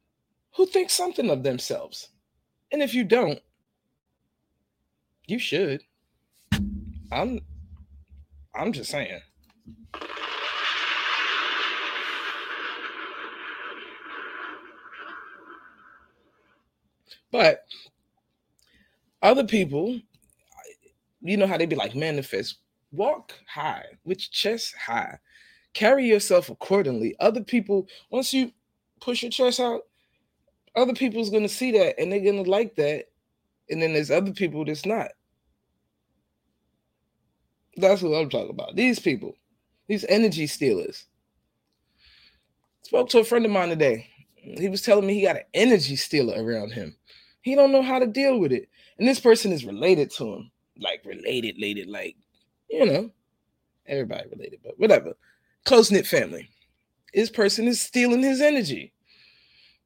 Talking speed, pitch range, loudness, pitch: 120 wpm, 155-250 Hz, -24 LUFS, 210 Hz